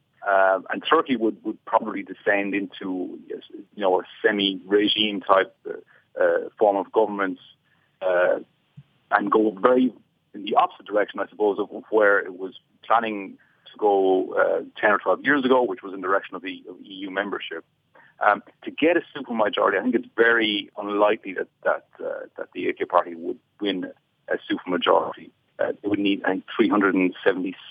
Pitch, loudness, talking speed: 130 Hz, -23 LUFS, 170 wpm